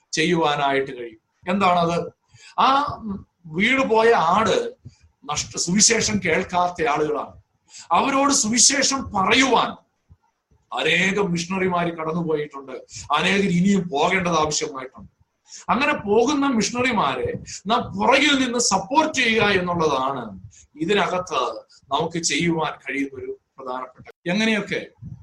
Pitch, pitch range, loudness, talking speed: 185 Hz, 155-230 Hz, -20 LUFS, 85 wpm